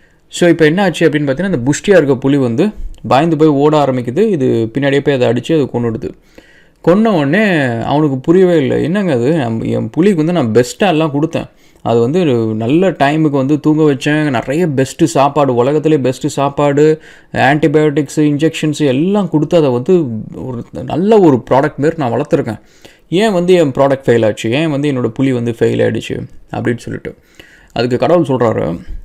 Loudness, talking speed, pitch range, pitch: -12 LUFS, 165 wpm, 130-160 Hz, 150 Hz